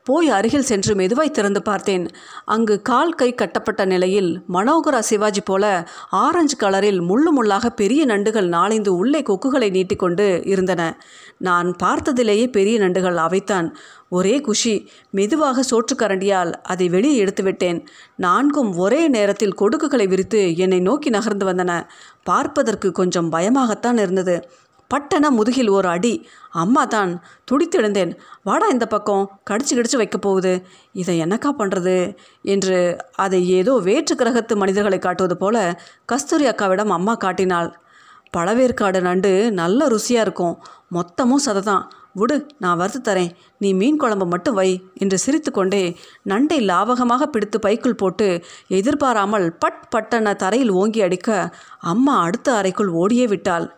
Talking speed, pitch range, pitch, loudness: 125 wpm, 185-245 Hz, 205 Hz, -18 LUFS